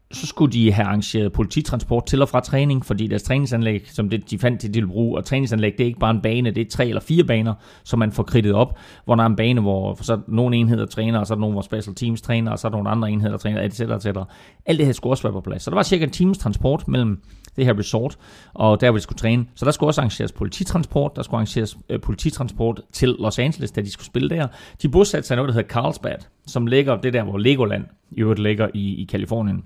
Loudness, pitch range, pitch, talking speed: -21 LUFS, 105-130 Hz, 115 Hz, 265 wpm